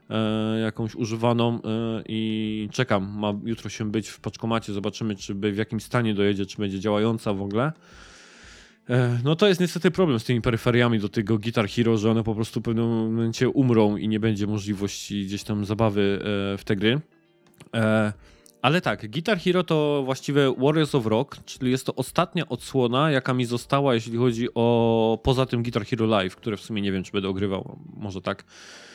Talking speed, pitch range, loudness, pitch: 180 wpm, 105-130 Hz, -24 LUFS, 115 Hz